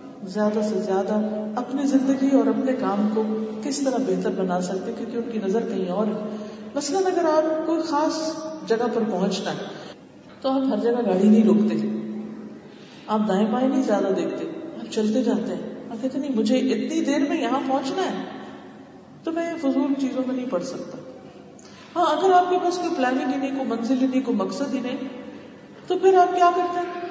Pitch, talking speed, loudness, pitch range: 255 Hz, 195 wpm, -23 LUFS, 215-280 Hz